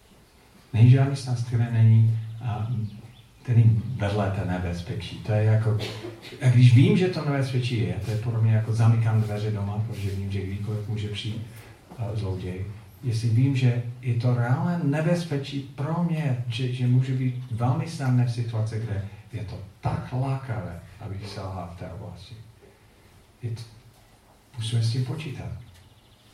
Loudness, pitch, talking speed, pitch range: -25 LUFS, 115 Hz, 150 wpm, 105-125 Hz